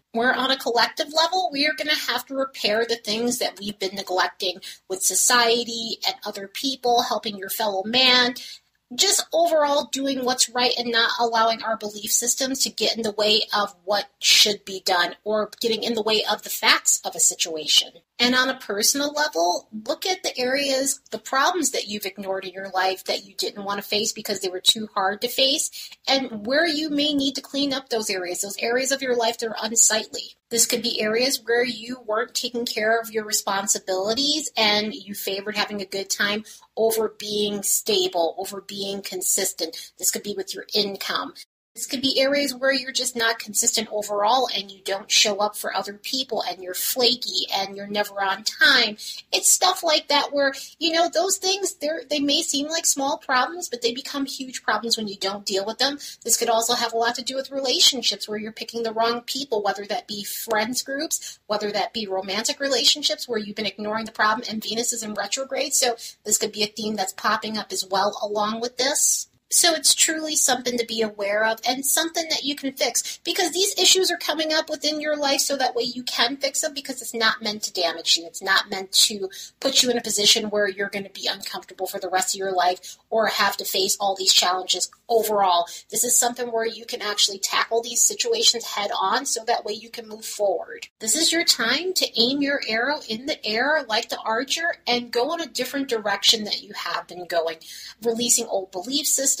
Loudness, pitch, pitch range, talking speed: -22 LUFS, 230 Hz, 205-270 Hz, 215 wpm